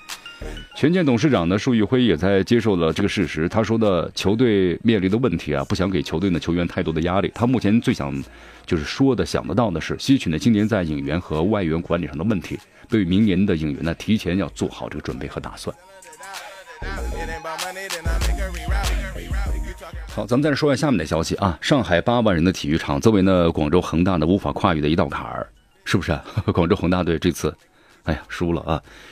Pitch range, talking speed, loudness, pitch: 80-110 Hz, 300 characters per minute, -21 LUFS, 90 Hz